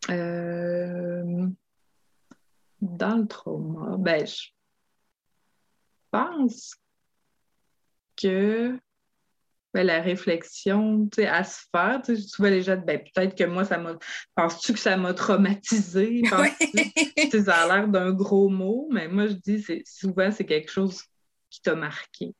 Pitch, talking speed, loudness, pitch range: 195 Hz, 135 wpm, -25 LUFS, 175-215 Hz